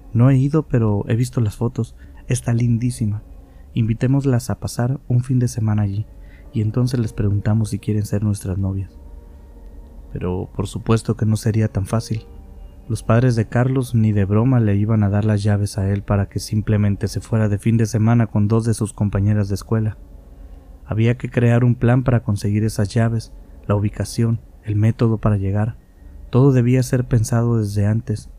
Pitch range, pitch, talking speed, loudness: 100-115 Hz, 110 Hz, 185 wpm, -19 LUFS